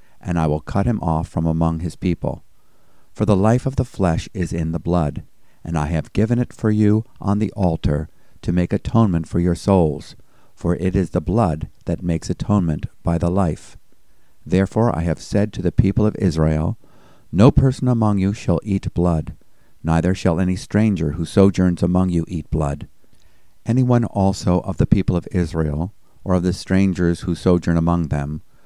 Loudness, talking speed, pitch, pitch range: -20 LUFS, 185 wpm, 90 Hz, 85-100 Hz